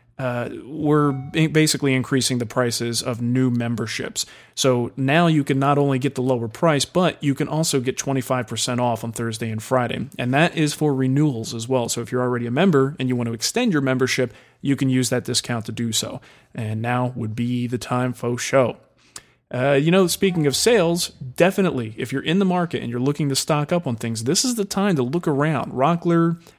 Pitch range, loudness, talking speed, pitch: 120-150 Hz, -21 LUFS, 215 wpm, 130 Hz